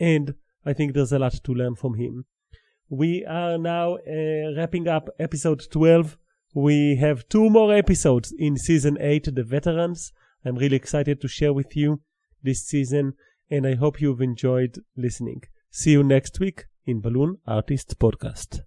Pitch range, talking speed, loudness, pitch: 130-160 Hz, 165 wpm, -23 LUFS, 145 Hz